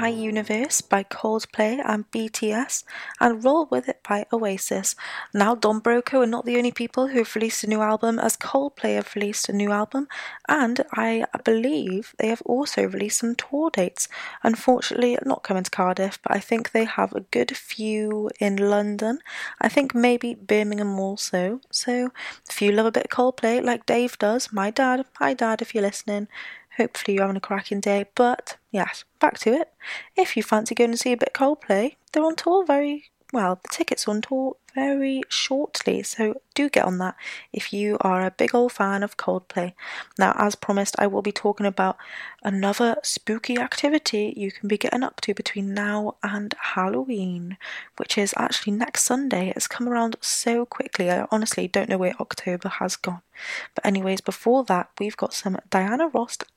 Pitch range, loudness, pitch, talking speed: 205-245 Hz, -24 LUFS, 220 Hz, 185 wpm